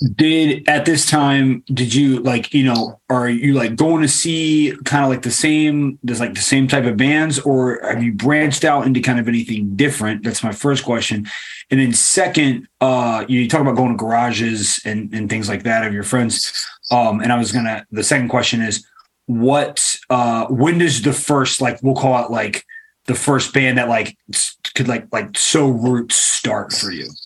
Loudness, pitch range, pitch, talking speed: -16 LUFS, 115-140 Hz, 125 Hz, 205 wpm